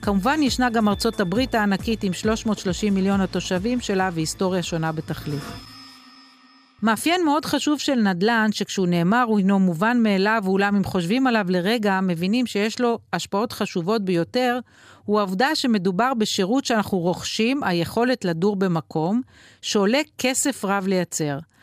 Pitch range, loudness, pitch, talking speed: 190-245 Hz, -22 LUFS, 210 Hz, 135 wpm